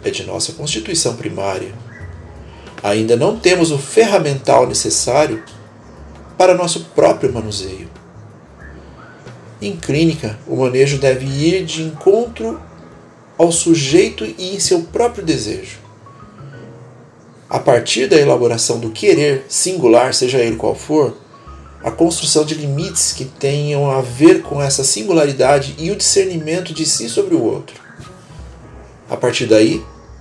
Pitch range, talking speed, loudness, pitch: 110-165 Hz, 125 wpm, -15 LUFS, 135 Hz